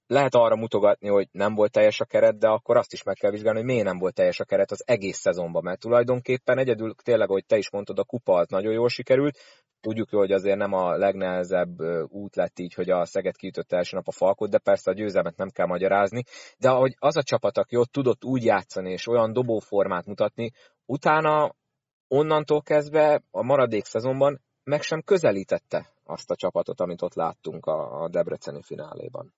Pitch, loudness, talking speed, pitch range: 120 Hz, -24 LUFS, 195 wpm, 100-140 Hz